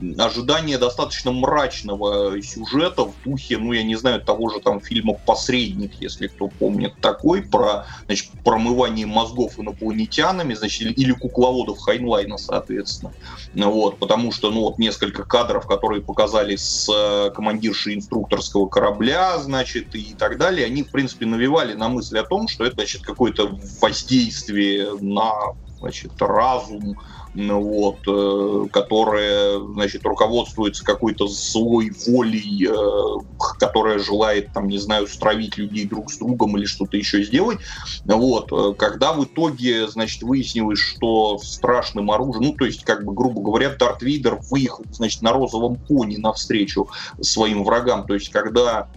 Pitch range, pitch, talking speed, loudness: 100-125 Hz, 110 Hz, 135 wpm, -20 LUFS